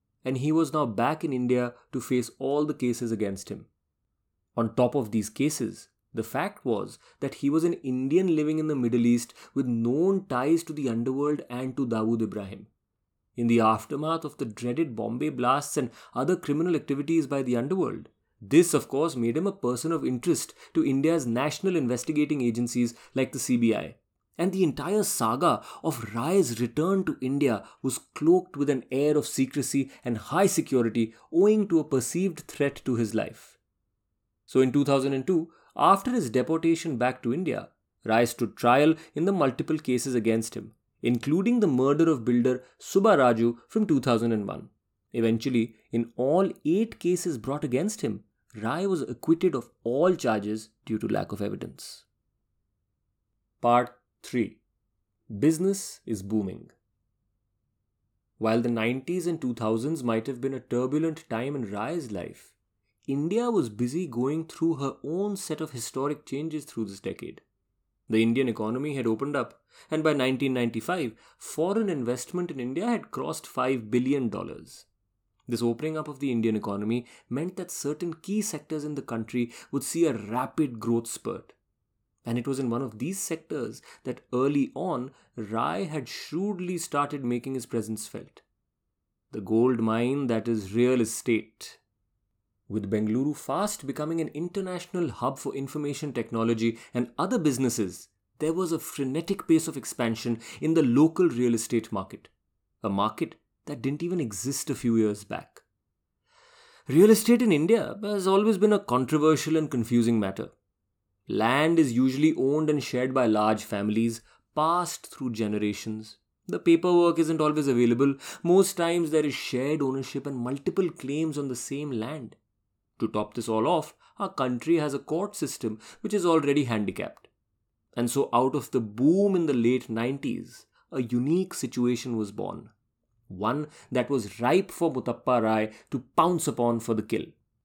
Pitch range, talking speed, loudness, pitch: 115-155 Hz, 160 wpm, -27 LUFS, 130 Hz